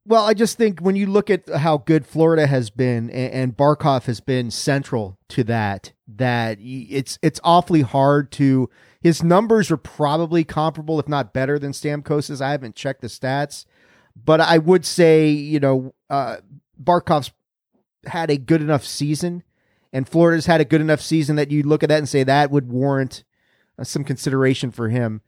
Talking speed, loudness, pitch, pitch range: 180 wpm, -19 LUFS, 145 Hz, 130-160 Hz